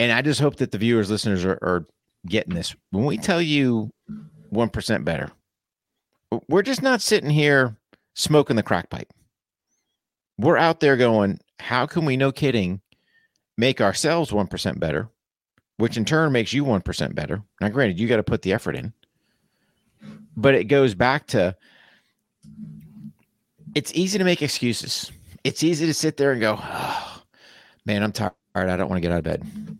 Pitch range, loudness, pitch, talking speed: 105-155 Hz, -22 LUFS, 125 Hz, 175 wpm